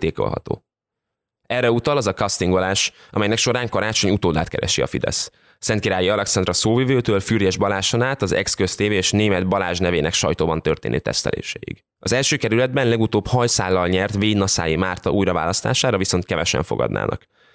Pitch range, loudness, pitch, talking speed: 95-115 Hz, -19 LUFS, 100 Hz, 135 wpm